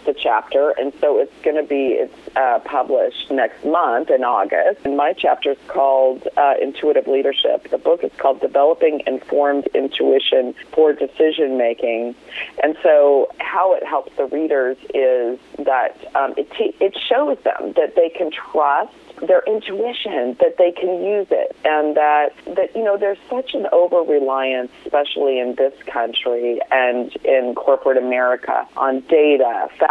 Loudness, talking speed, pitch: -18 LUFS, 160 wpm, 150 Hz